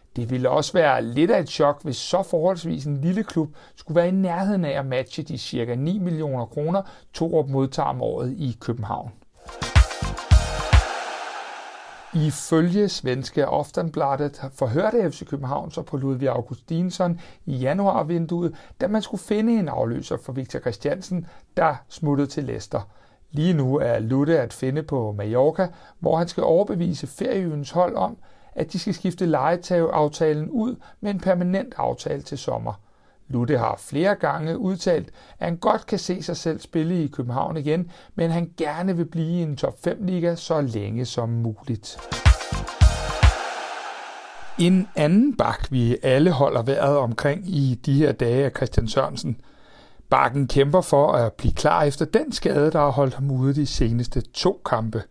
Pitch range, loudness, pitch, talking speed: 135-180 Hz, -23 LUFS, 155 Hz, 160 wpm